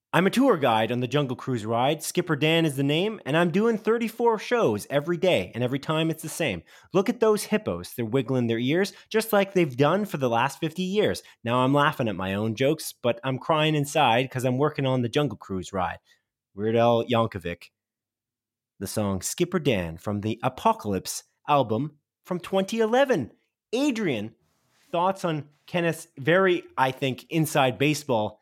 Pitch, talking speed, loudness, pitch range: 145 Hz, 180 wpm, -25 LUFS, 115-175 Hz